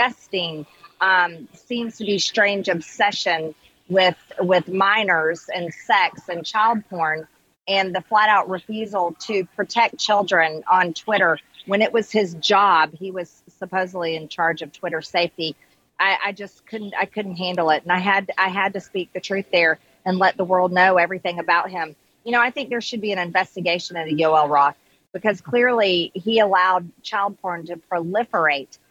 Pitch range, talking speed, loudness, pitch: 170-200 Hz, 170 wpm, -20 LUFS, 185 Hz